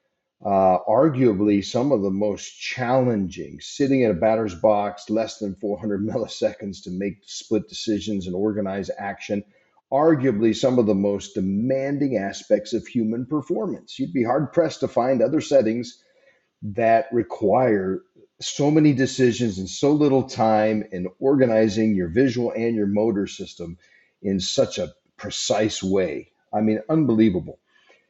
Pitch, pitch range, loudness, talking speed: 110 Hz, 100-125 Hz, -22 LUFS, 140 wpm